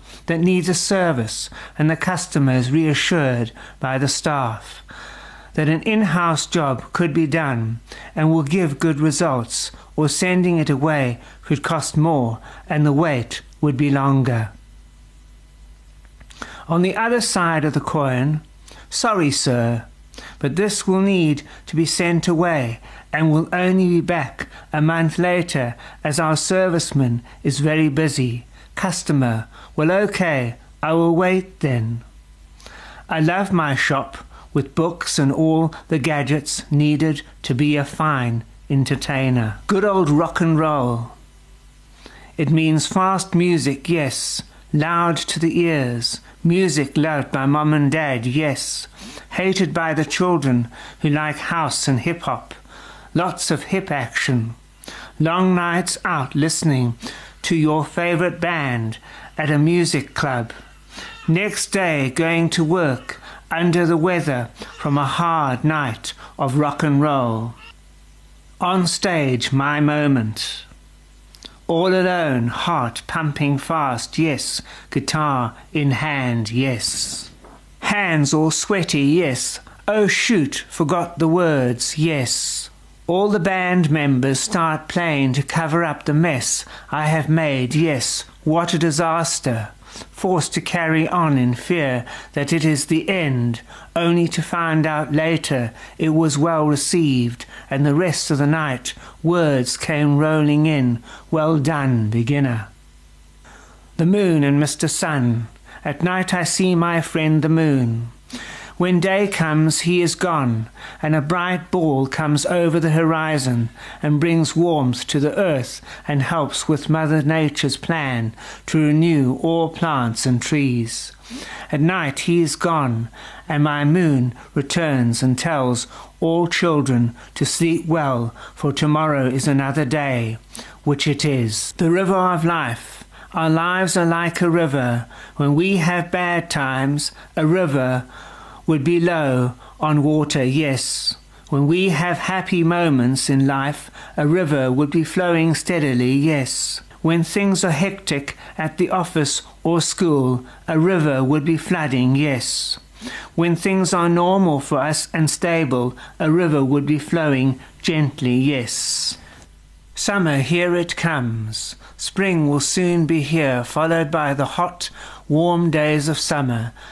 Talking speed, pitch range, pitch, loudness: 140 wpm, 130-170 Hz, 155 Hz, -19 LUFS